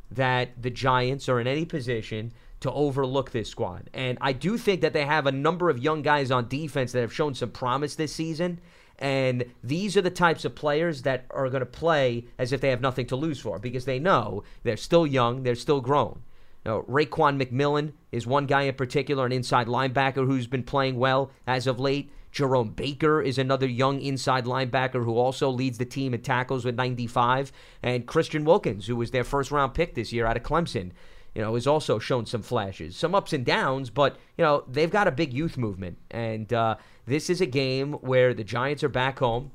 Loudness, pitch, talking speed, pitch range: -26 LUFS, 135 Hz, 215 wpm, 125-150 Hz